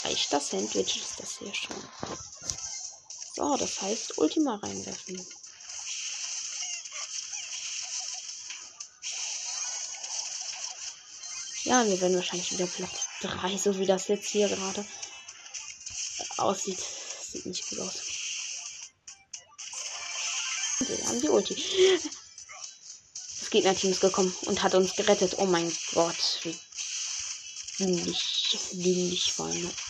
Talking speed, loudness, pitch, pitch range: 95 wpm, -29 LUFS, 190 Hz, 180-205 Hz